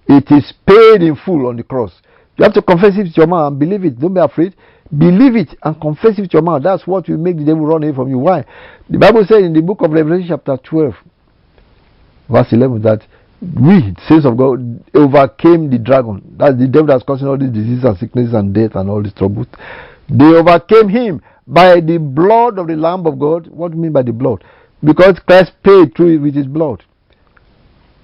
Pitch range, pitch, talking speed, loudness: 135-175 Hz, 155 Hz, 220 wpm, -11 LUFS